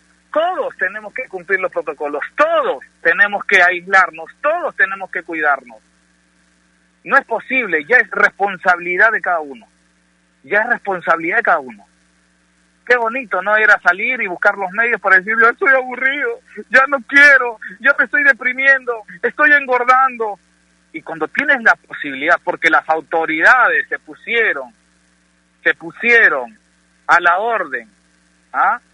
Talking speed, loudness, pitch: 145 wpm, -14 LUFS, 190 Hz